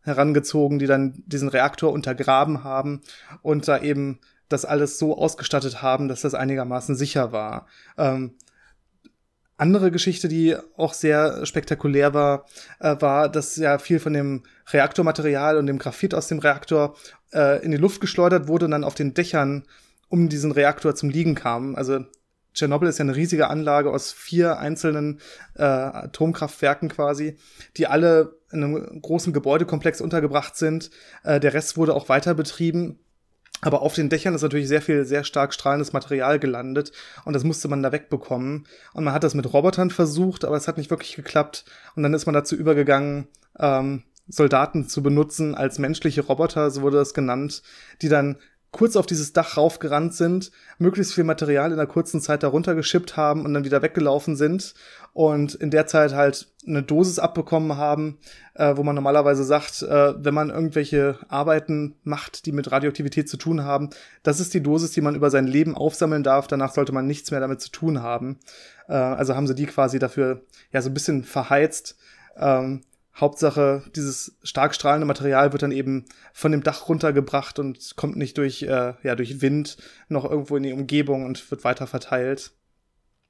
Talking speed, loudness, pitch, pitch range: 180 wpm, -22 LUFS, 145 Hz, 140-155 Hz